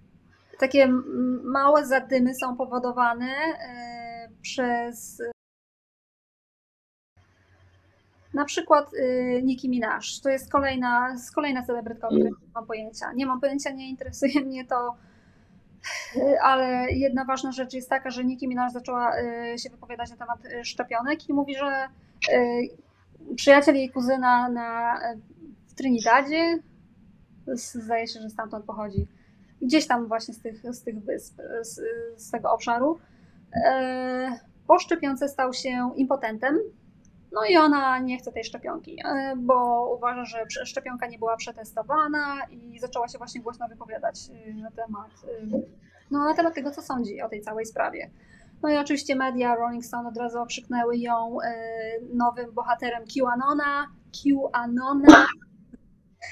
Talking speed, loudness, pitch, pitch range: 125 wpm, -25 LUFS, 250 Hz, 235-275 Hz